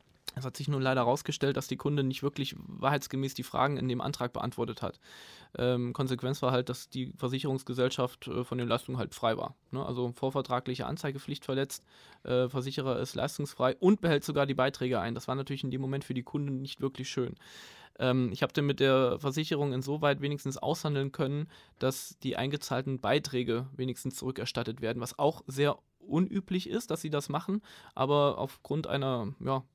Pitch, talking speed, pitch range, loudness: 135 Hz, 185 wpm, 125-145 Hz, -32 LUFS